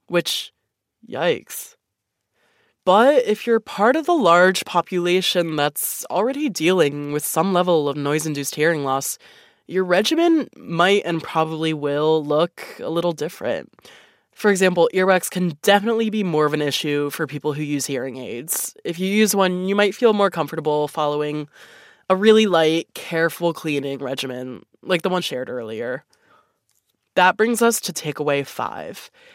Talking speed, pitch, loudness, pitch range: 150 wpm, 175 Hz, -20 LUFS, 150-205 Hz